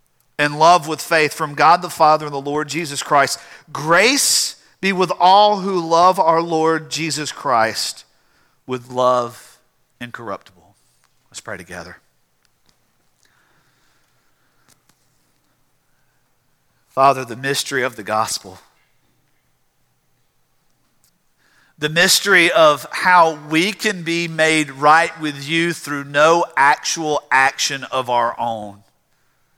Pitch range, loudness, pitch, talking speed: 125-165 Hz, -16 LUFS, 145 Hz, 110 wpm